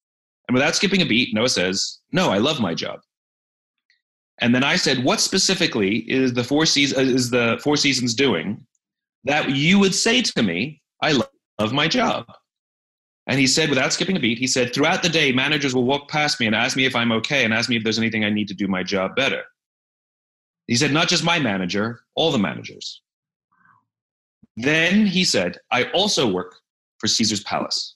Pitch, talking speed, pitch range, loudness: 135 Hz, 195 wpm, 115-170 Hz, -19 LUFS